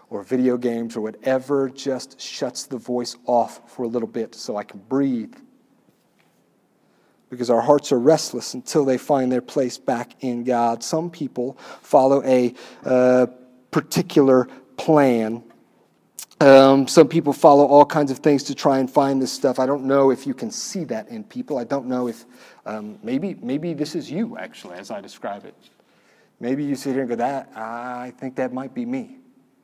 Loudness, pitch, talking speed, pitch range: -20 LUFS, 135 Hz, 180 wpm, 125-150 Hz